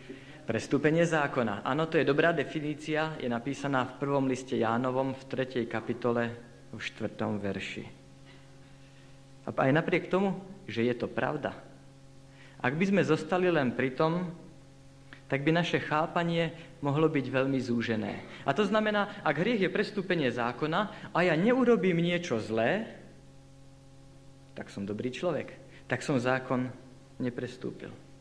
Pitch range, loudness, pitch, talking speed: 130-160 Hz, -30 LUFS, 135 Hz, 135 wpm